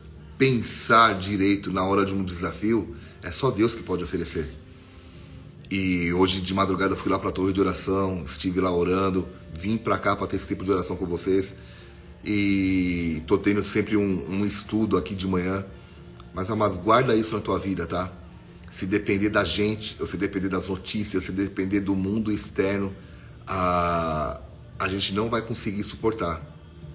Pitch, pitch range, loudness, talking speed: 95 Hz, 90-105 Hz, -25 LUFS, 175 wpm